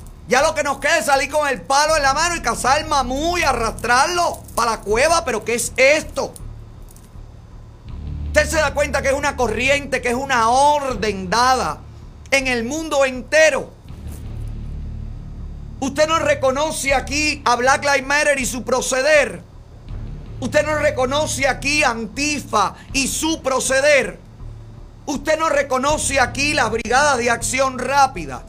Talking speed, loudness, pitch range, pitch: 150 wpm, -17 LUFS, 235-295 Hz, 270 Hz